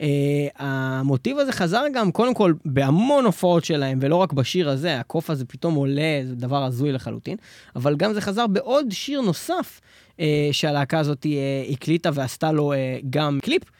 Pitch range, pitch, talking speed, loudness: 140-185 Hz, 150 Hz, 170 wpm, -22 LUFS